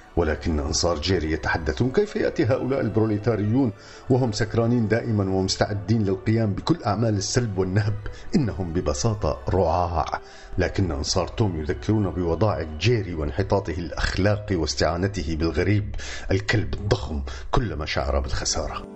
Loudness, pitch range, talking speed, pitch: -24 LUFS, 85-110 Hz, 110 wpm, 100 Hz